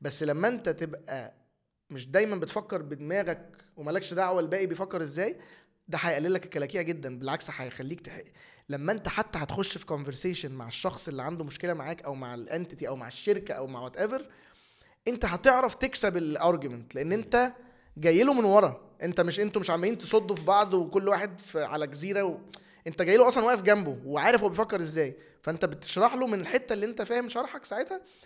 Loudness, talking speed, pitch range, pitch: -29 LUFS, 185 wpm, 155-210 Hz, 185 Hz